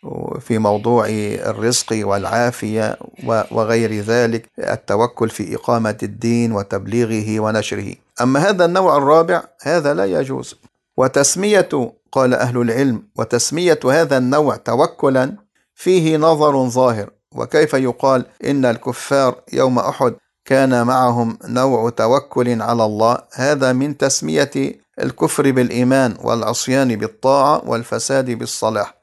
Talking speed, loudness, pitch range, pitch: 105 wpm, -17 LUFS, 115-135 Hz, 125 Hz